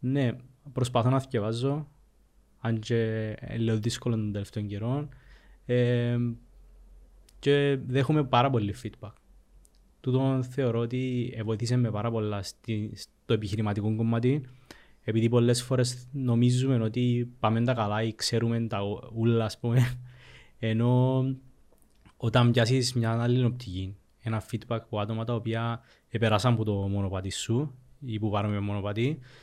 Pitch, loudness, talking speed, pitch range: 115 Hz, -28 LUFS, 130 wpm, 105-125 Hz